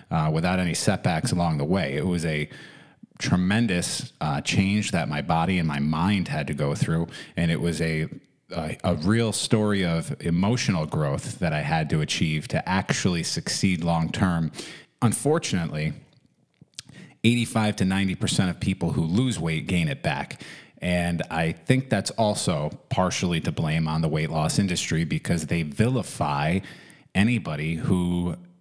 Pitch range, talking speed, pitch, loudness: 80-105 Hz, 160 wpm, 90 Hz, -25 LUFS